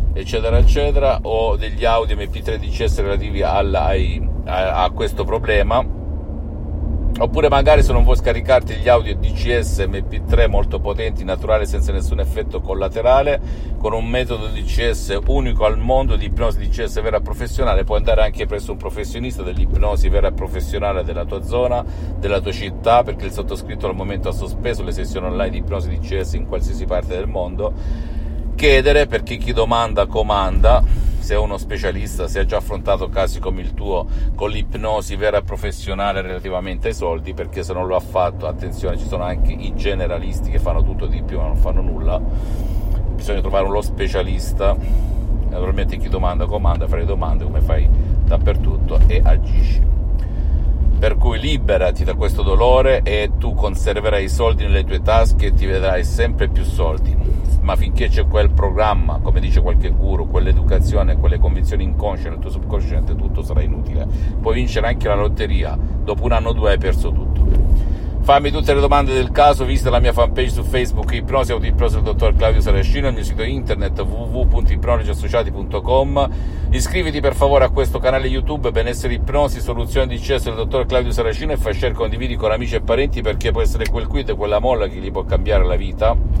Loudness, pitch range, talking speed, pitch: -19 LUFS, 75-100 Hz, 175 wpm, 80 Hz